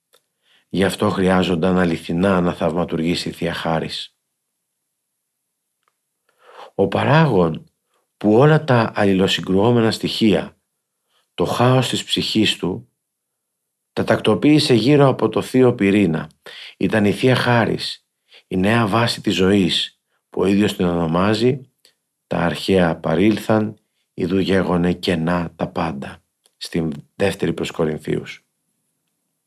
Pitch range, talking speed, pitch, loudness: 90-115 Hz, 110 wpm, 100 Hz, -18 LUFS